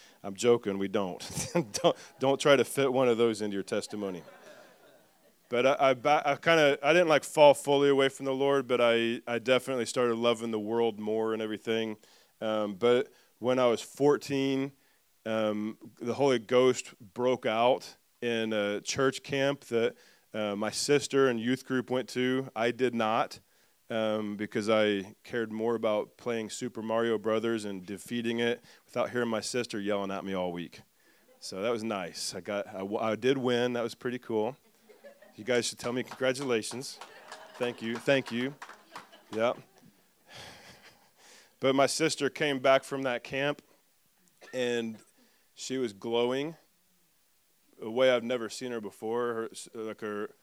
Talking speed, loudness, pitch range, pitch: 165 wpm, -29 LUFS, 110-130 Hz, 120 Hz